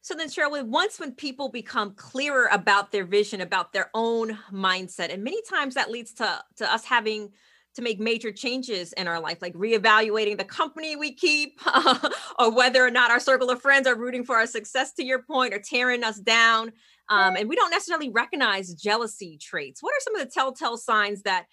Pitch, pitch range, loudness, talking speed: 235 Hz, 210-270 Hz, -24 LUFS, 205 wpm